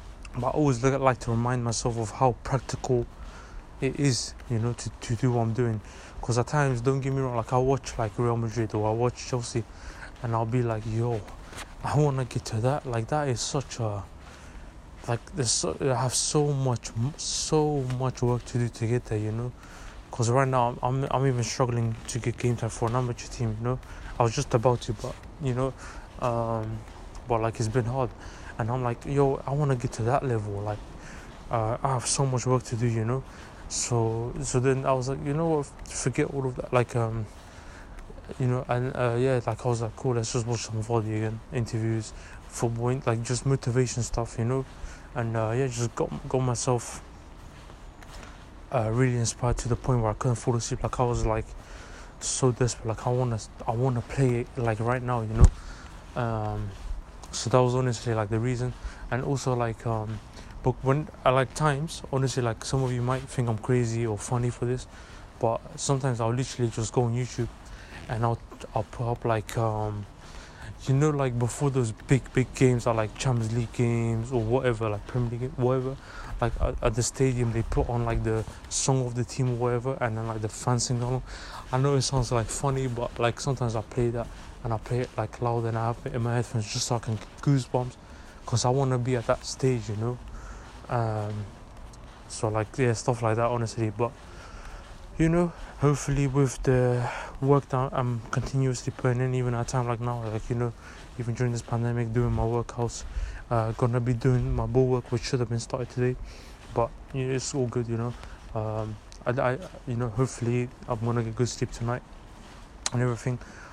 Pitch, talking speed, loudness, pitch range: 120 Hz, 210 wpm, -28 LUFS, 110-130 Hz